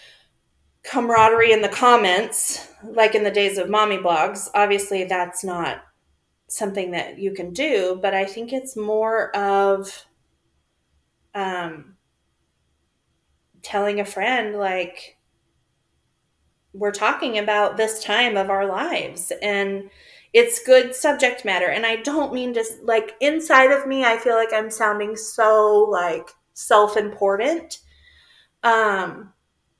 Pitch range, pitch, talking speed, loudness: 185-225 Hz, 205 Hz, 125 wpm, -19 LUFS